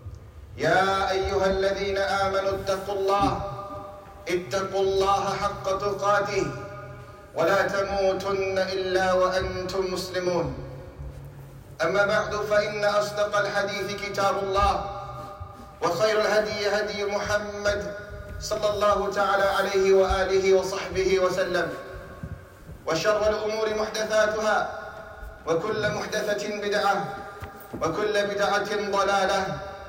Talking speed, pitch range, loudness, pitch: 85 wpm, 190-205 Hz, -25 LUFS, 195 Hz